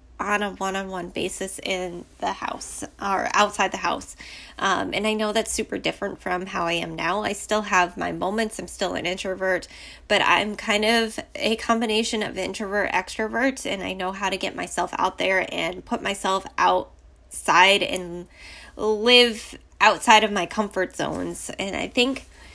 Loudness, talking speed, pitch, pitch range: -23 LUFS, 175 wpm, 200 Hz, 185-220 Hz